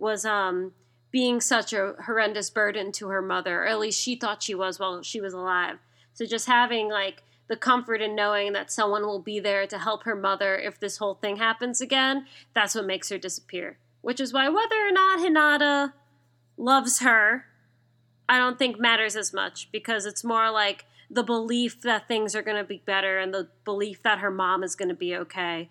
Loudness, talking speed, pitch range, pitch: -25 LUFS, 205 wpm, 190-230 Hz, 210 Hz